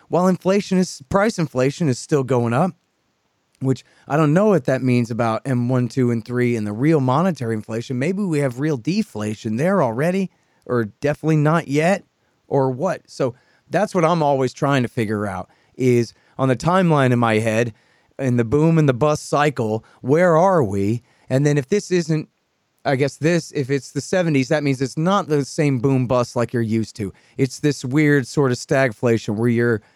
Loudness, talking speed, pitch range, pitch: -20 LUFS, 195 wpm, 120-155 Hz, 135 Hz